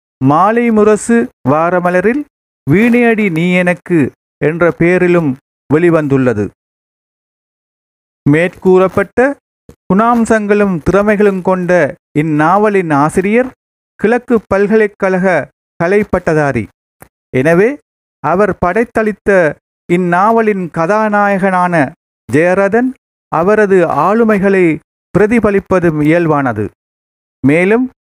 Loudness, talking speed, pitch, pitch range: -11 LUFS, 60 wpm, 185 Hz, 160-215 Hz